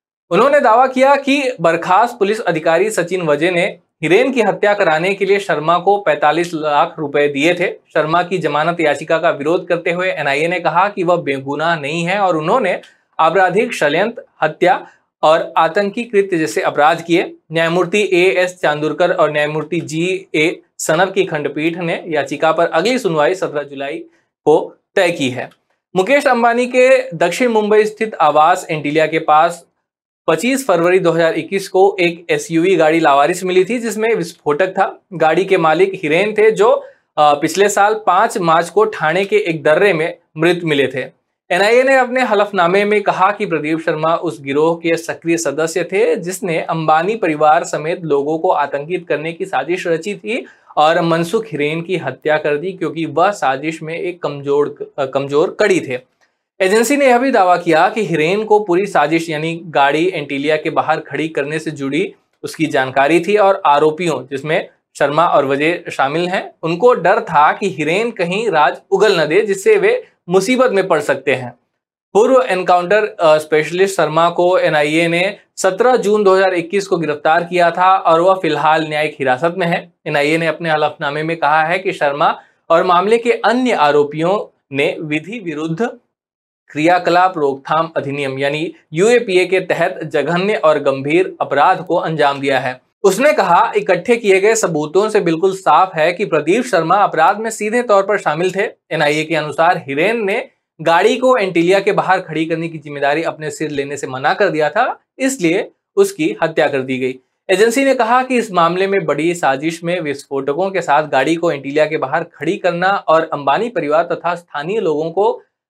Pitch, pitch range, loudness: 170 Hz, 155-200 Hz, -15 LUFS